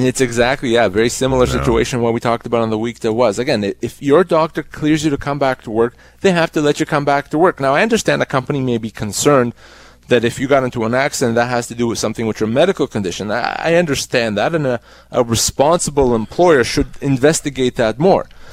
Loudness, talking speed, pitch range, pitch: -16 LUFS, 235 wpm, 115-145 Hz, 130 Hz